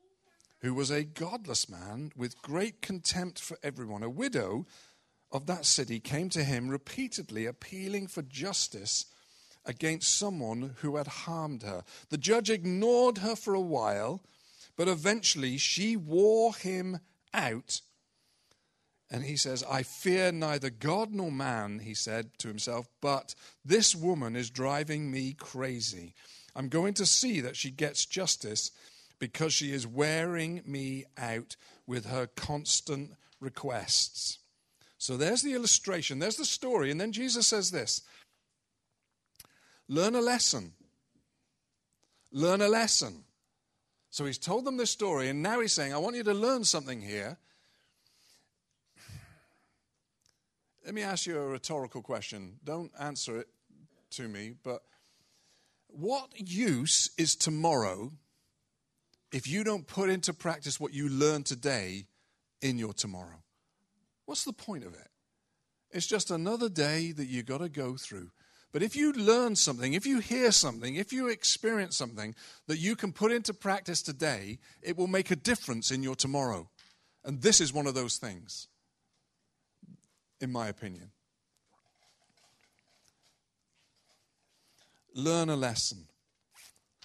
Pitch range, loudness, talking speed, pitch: 125-190 Hz, -31 LUFS, 140 wpm, 150 Hz